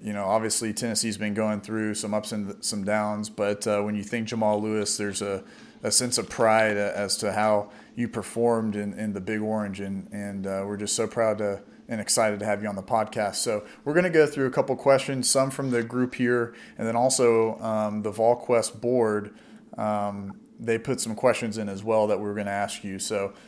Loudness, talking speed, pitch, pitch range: -26 LUFS, 225 wpm, 110 Hz, 105-115 Hz